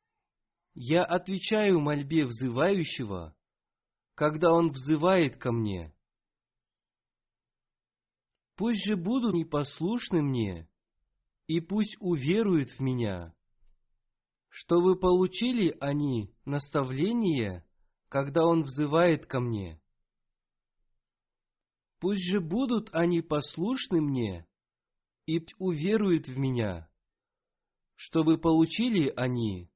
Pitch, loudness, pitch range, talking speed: 150 Hz, -28 LUFS, 115-175 Hz, 90 wpm